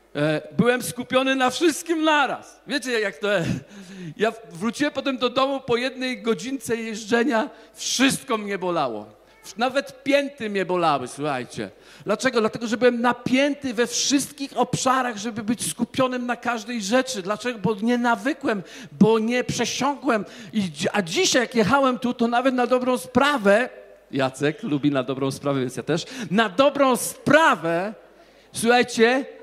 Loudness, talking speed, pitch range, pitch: -22 LUFS, 140 wpm, 200-255 Hz, 235 Hz